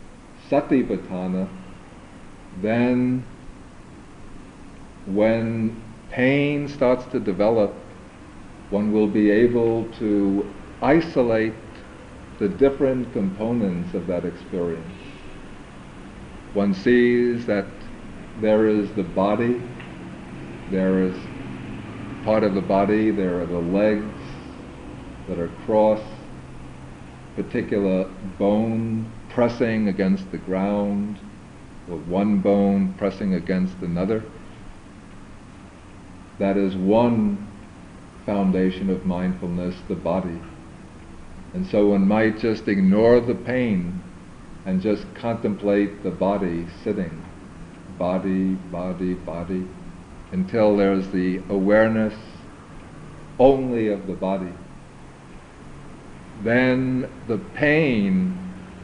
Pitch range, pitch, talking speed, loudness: 95-110 Hz, 100 Hz, 90 wpm, -22 LUFS